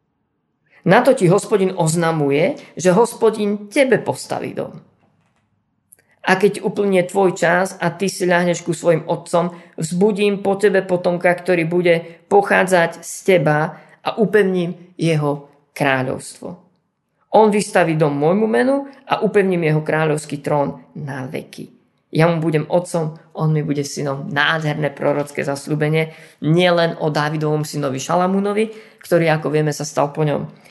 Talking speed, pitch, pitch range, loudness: 135 wpm, 170 Hz, 155-190 Hz, -18 LUFS